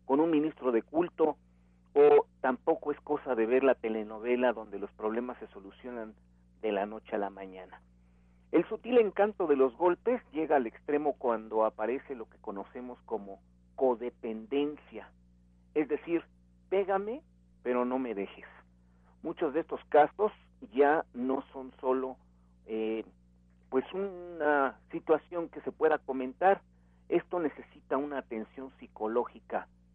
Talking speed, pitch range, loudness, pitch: 135 wpm, 90-145 Hz, -31 LUFS, 125 Hz